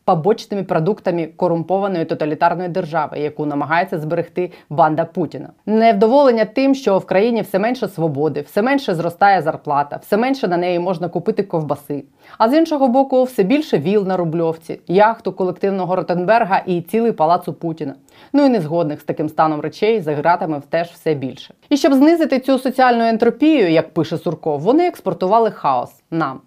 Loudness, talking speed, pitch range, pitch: -17 LUFS, 160 wpm, 165-225 Hz, 185 Hz